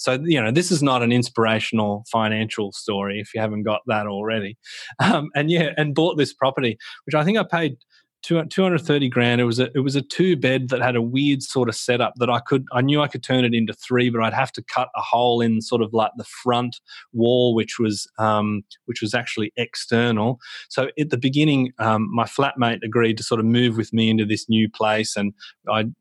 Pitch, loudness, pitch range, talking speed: 120 Hz, -21 LUFS, 110-135 Hz, 225 wpm